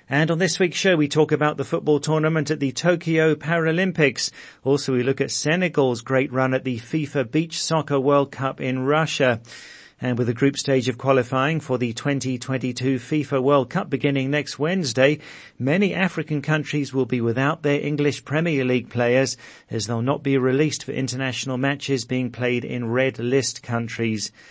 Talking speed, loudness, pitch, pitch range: 175 wpm, -22 LUFS, 135 Hz, 130-150 Hz